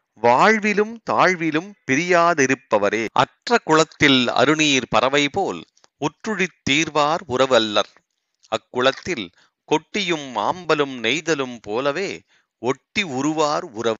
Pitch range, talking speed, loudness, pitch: 130-175 Hz, 75 wpm, -19 LUFS, 155 Hz